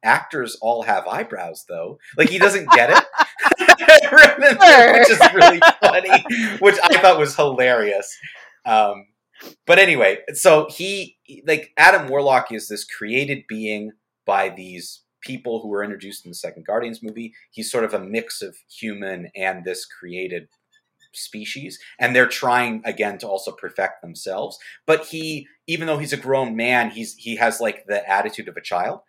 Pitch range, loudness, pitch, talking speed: 105-165 Hz, -14 LUFS, 120 Hz, 160 wpm